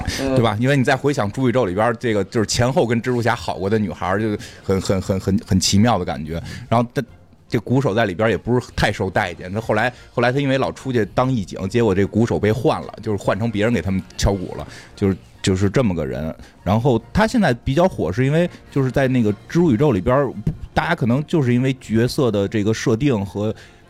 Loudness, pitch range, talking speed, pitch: -19 LUFS, 100-125 Hz, 340 characters per minute, 110 Hz